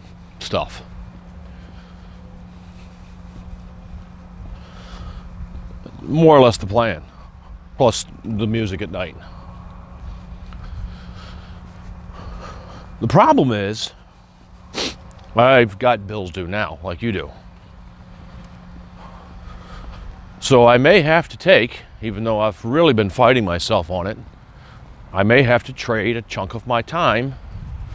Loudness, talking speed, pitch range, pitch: -17 LUFS, 100 wpm, 90-110 Hz, 90 Hz